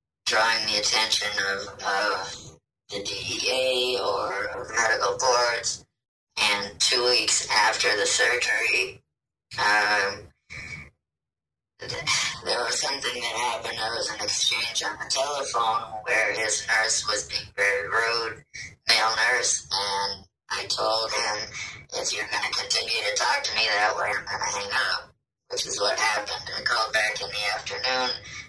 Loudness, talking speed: -24 LUFS, 150 wpm